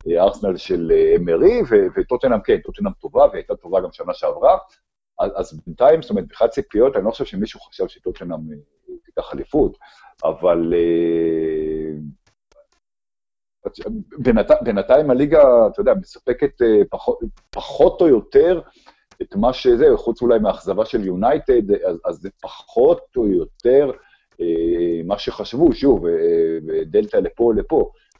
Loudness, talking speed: -18 LUFS, 115 wpm